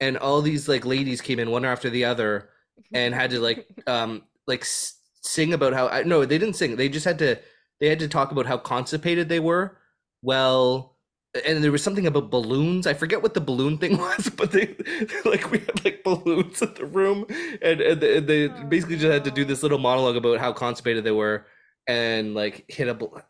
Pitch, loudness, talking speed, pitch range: 140 Hz, -23 LUFS, 210 wpm, 125-165 Hz